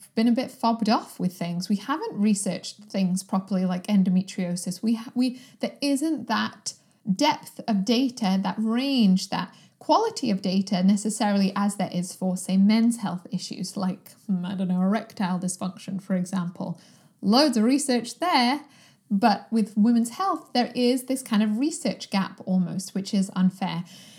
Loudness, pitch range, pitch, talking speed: -25 LUFS, 185-235 Hz, 205 Hz, 160 wpm